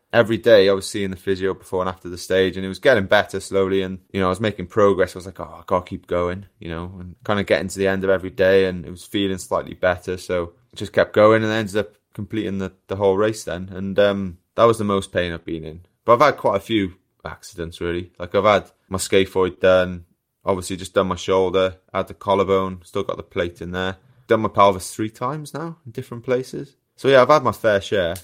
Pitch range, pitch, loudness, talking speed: 90-105 Hz, 95 Hz, -20 LUFS, 255 wpm